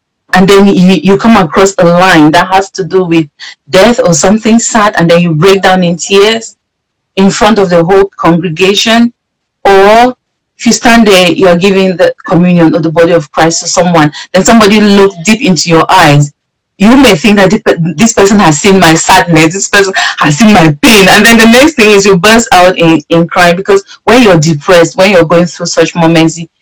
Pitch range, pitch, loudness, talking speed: 170-205 Hz, 190 Hz, -5 LUFS, 205 wpm